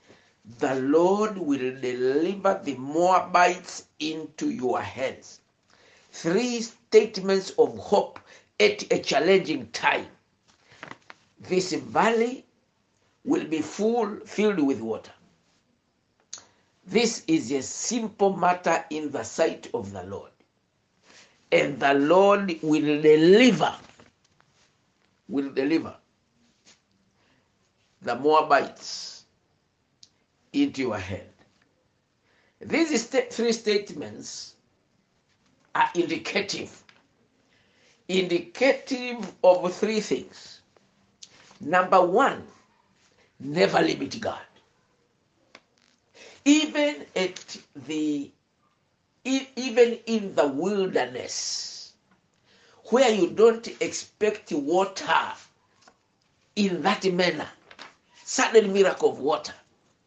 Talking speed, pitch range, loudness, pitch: 80 wpm, 165-235 Hz, -24 LUFS, 195 Hz